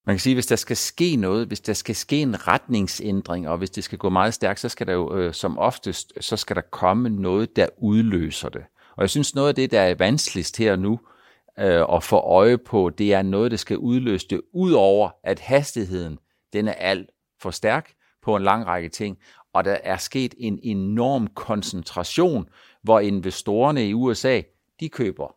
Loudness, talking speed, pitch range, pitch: -22 LUFS, 200 wpm, 95-120 Hz, 105 Hz